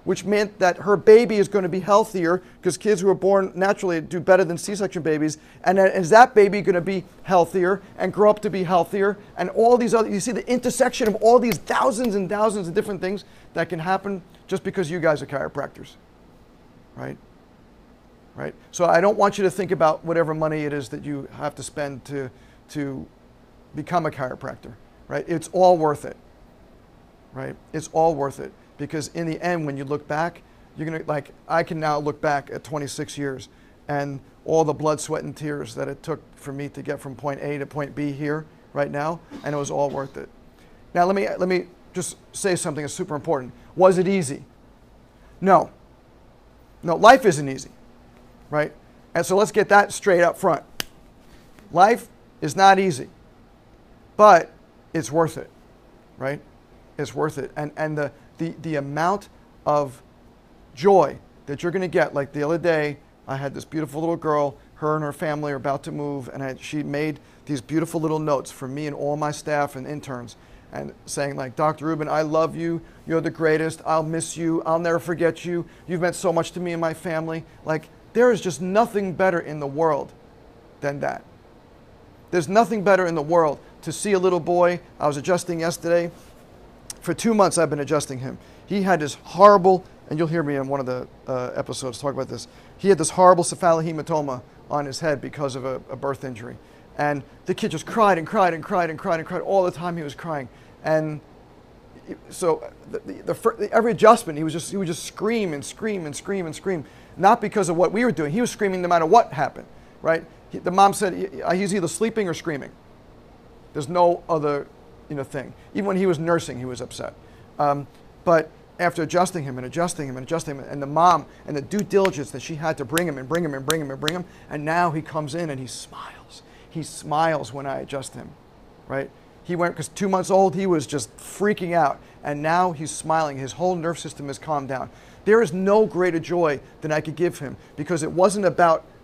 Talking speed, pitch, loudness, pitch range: 210 wpm, 160 Hz, -22 LUFS, 145-185 Hz